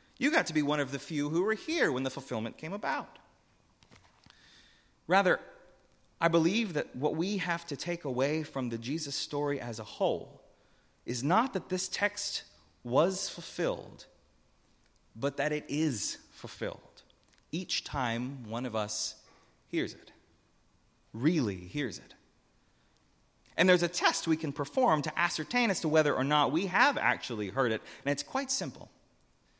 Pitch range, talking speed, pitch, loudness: 120-165 Hz, 160 wpm, 145 Hz, -31 LUFS